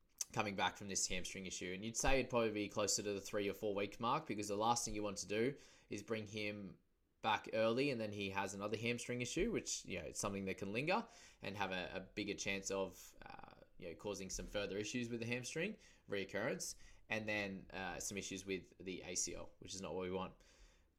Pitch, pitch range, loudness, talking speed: 100 Hz, 95-110 Hz, -42 LUFS, 230 wpm